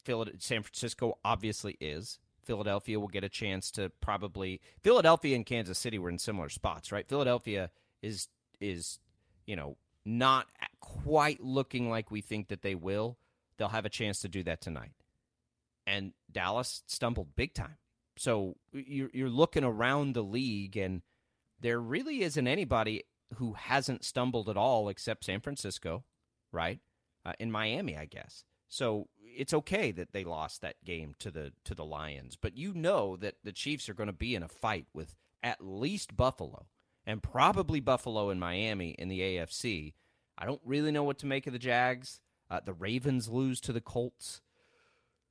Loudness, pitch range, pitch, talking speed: -34 LUFS, 95-125 Hz, 105 Hz, 170 wpm